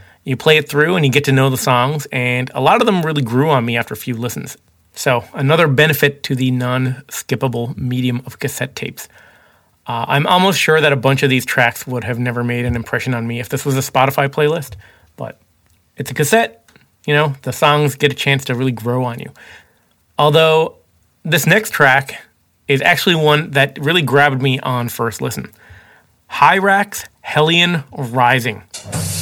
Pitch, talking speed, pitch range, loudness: 135 Hz, 190 wpm, 125-150 Hz, -15 LUFS